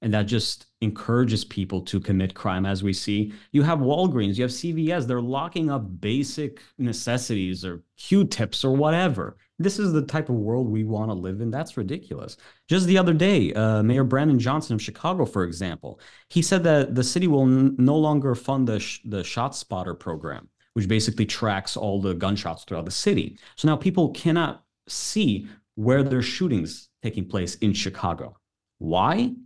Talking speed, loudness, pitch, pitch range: 180 wpm, -24 LUFS, 120 Hz, 105-150 Hz